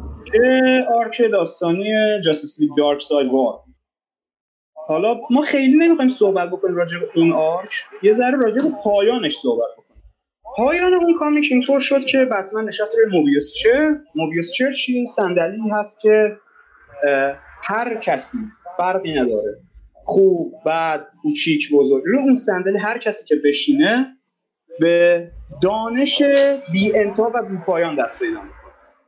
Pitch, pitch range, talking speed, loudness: 215 Hz, 170-265 Hz, 130 wpm, -17 LUFS